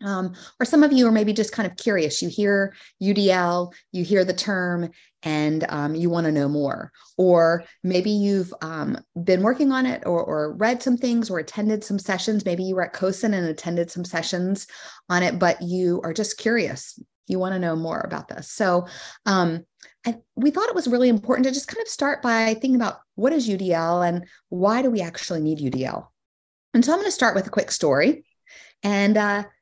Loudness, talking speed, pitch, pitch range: -22 LUFS, 210 wpm, 190 Hz, 170-225 Hz